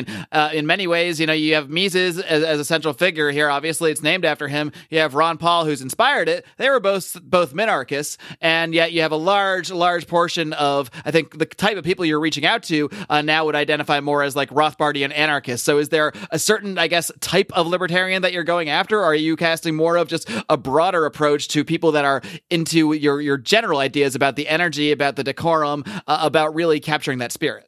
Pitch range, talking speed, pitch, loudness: 150-170 Hz, 230 wpm, 155 Hz, -19 LUFS